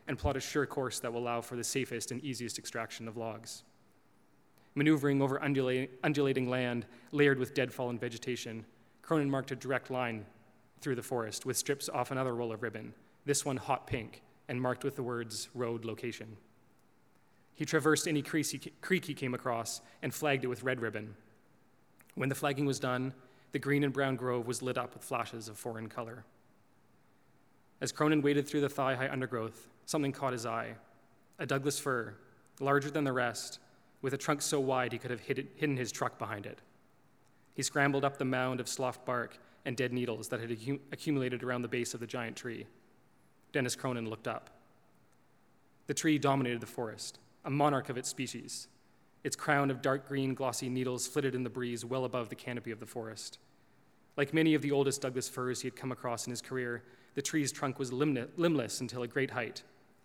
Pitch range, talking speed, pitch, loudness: 120-140 Hz, 190 wpm, 130 Hz, -35 LUFS